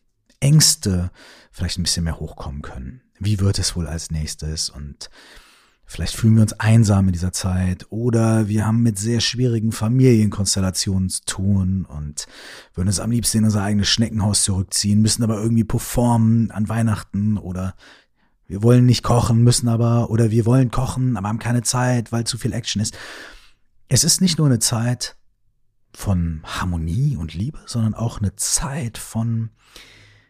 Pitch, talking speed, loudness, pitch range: 110 Hz, 160 wpm, -19 LUFS, 95-115 Hz